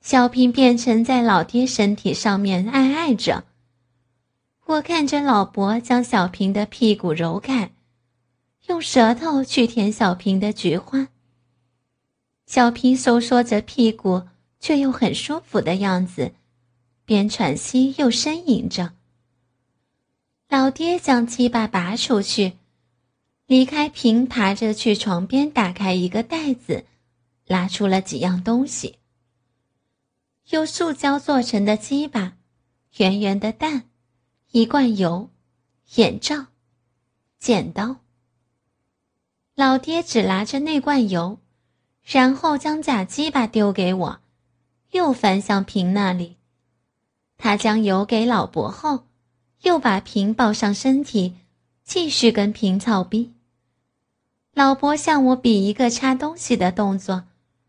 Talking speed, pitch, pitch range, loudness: 170 characters per minute, 210 Hz, 170-255 Hz, -20 LUFS